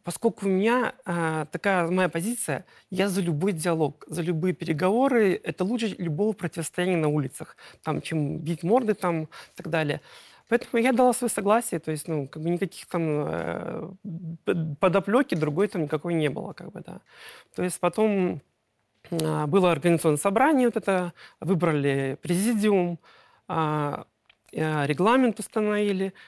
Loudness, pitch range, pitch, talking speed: -26 LUFS, 160-205 Hz, 175 Hz, 135 wpm